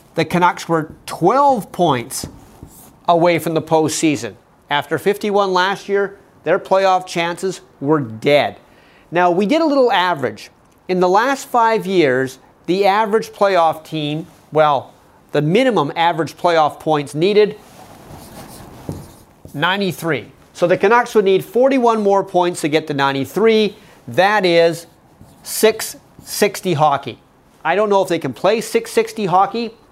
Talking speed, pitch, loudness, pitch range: 130 wpm, 180 Hz, -16 LUFS, 155-210 Hz